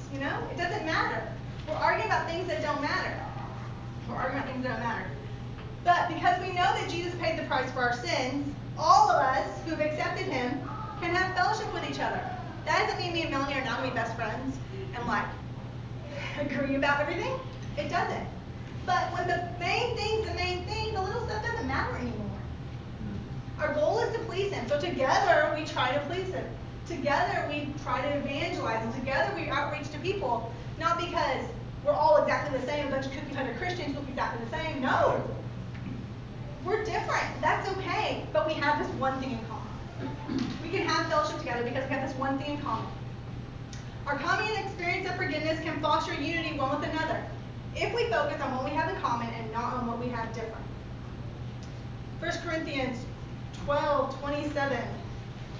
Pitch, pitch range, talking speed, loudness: 305 Hz, 270-355 Hz, 190 wpm, -30 LUFS